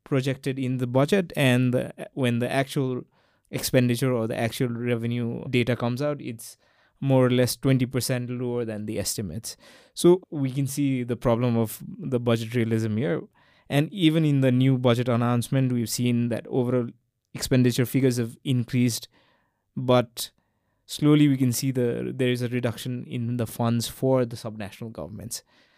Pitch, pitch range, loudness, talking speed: 125 Hz, 120-135 Hz, -25 LUFS, 160 wpm